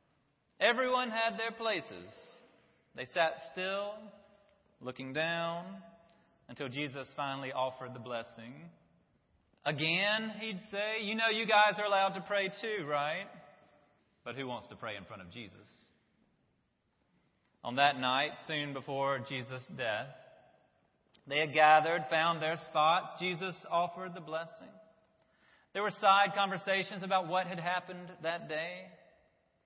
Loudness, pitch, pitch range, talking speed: -33 LUFS, 170 Hz, 140-200 Hz, 130 wpm